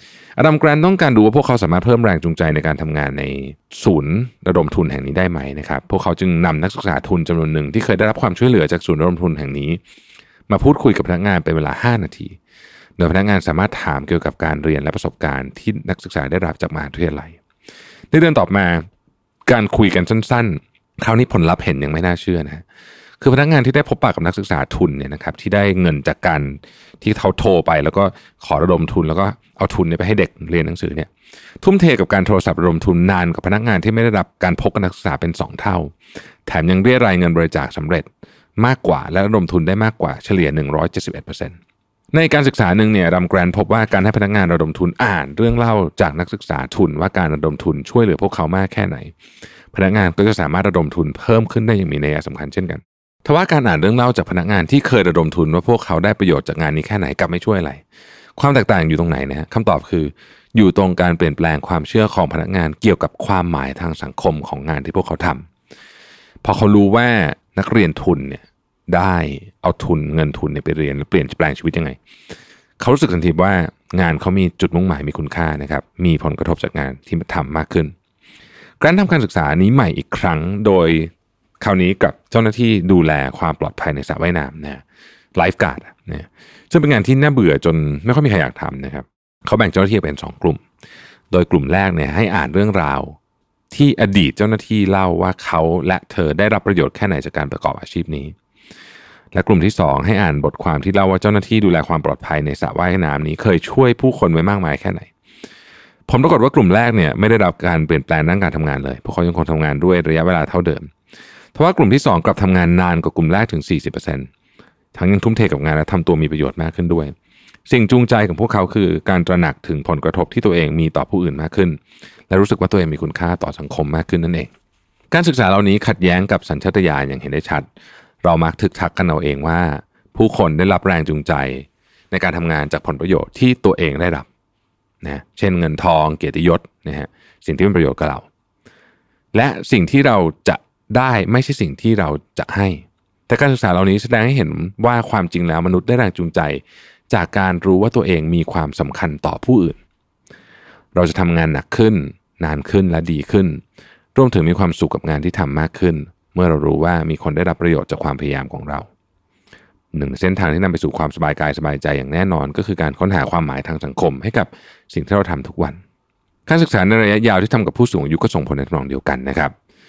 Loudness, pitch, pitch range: -16 LUFS, 90 Hz, 80-105 Hz